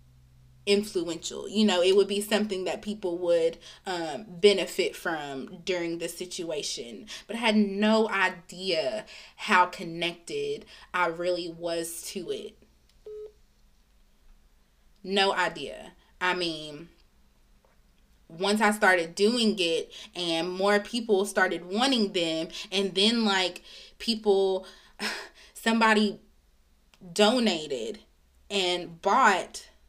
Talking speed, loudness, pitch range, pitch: 100 wpm, -27 LUFS, 170-210 Hz, 190 Hz